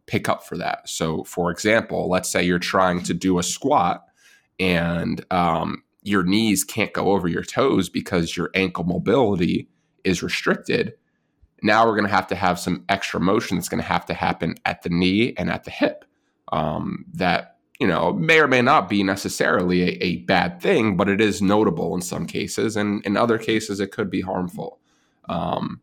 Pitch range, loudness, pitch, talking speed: 90-105 Hz, -21 LUFS, 95 Hz, 195 wpm